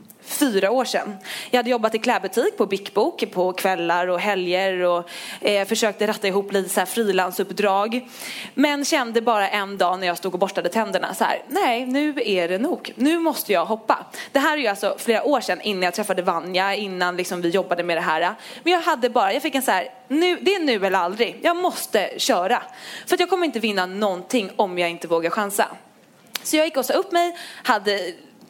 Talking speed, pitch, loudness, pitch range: 215 wpm, 210 Hz, -22 LUFS, 185-260 Hz